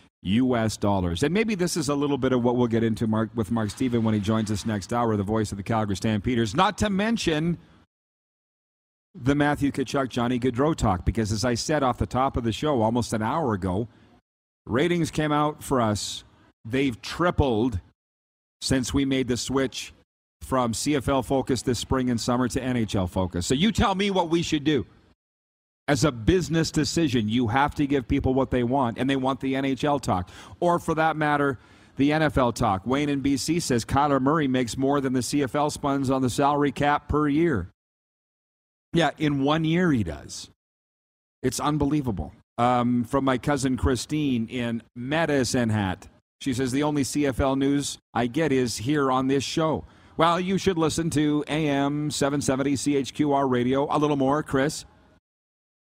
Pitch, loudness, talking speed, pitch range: 130 Hz, -24 LUFS, 180 wpm, 110-145 Hz